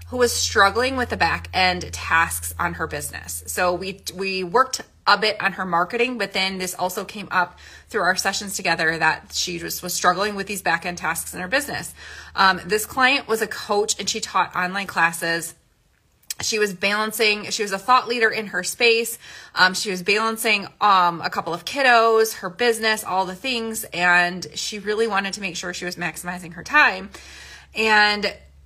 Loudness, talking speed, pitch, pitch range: -21 LUFS, 195 wpm, 195 Hz, 180-220 Hz